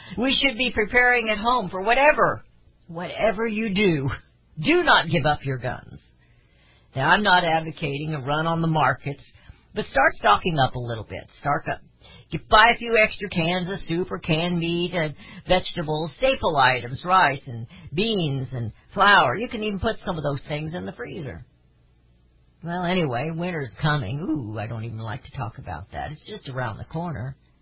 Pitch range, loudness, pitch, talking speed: 125-190 Hz, -22 LUFS, 160 Hz, 185 wpm